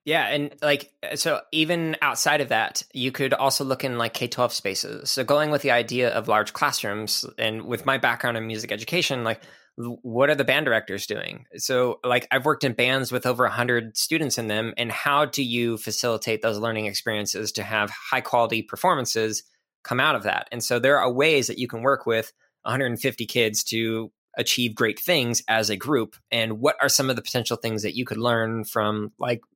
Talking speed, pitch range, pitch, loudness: 215 wpm, 110-135 Hz, 120 Hz, -23 LUFS